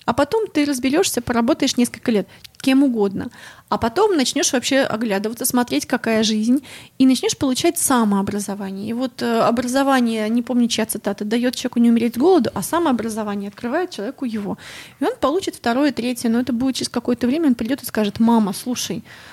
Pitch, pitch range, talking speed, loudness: 245 Hz, 225-275 Hz, 175 wpm, -19 LUFS